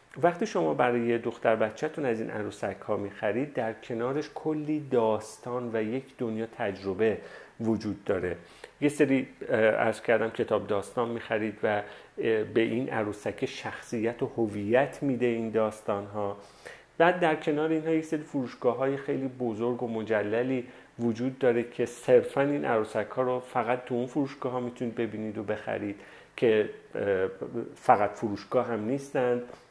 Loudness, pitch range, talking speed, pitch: -29 LUFS, 110-140 Hz, 155 wpm, 120 Hz